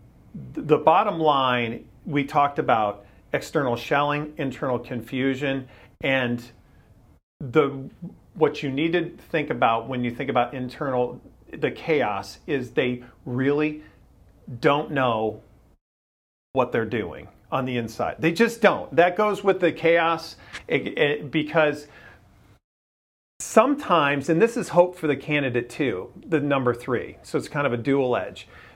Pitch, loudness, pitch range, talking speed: 140 Hz, -23 LUFS, 120-155 Hz, 135 wpm